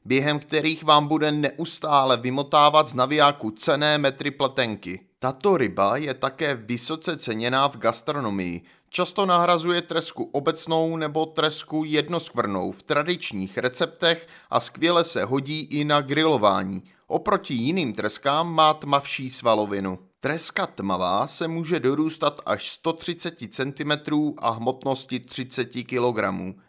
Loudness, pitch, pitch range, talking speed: -23 LUFS, 145 Hz, 125-160 Hz, 120 wpm